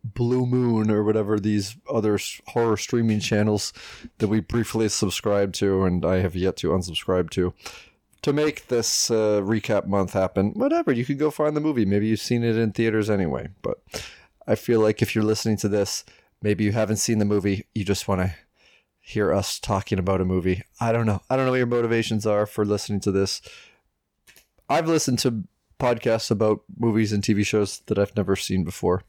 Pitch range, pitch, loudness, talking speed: 100-115 Hz, 105 Hz, -23 LUFS, 195 wpm